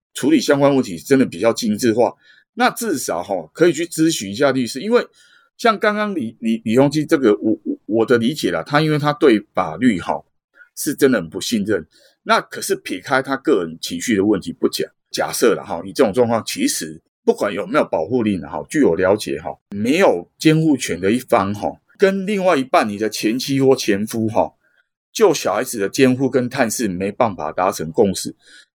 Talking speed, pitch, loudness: 290 characters per minute, 140 Hz, -18 LUFS